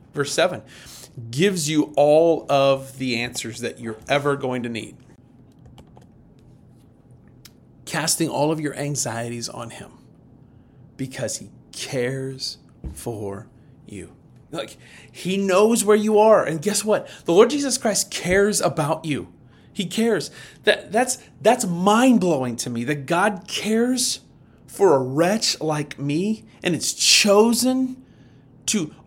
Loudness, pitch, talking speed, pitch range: -21 LUFS, 150 Hz, 130 wpm, 130-210 Hz